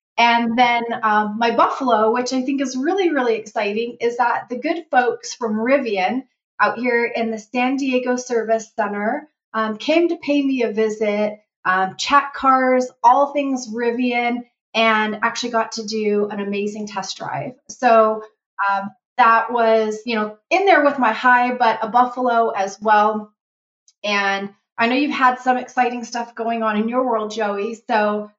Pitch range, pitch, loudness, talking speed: 215-250 Hz, 230 Hz, -19 LUFS, 170 wpm